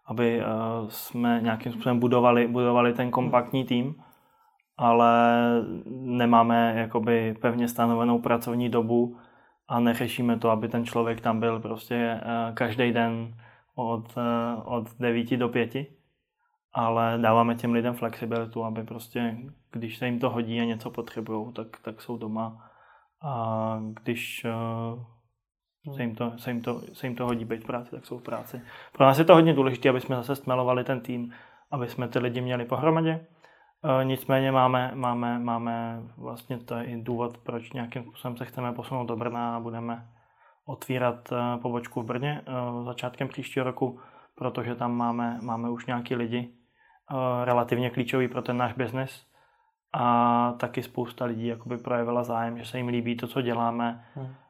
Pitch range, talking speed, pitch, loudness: 115-125 Hz, 155 wpm, 120 Hz, -27 LUFS